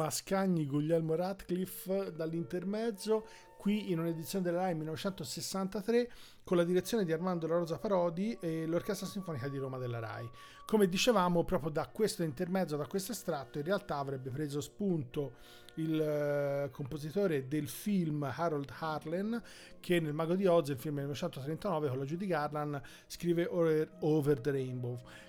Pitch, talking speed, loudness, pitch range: 165 Hz, 150 wpm, -35 LUFS, 145-185 Hz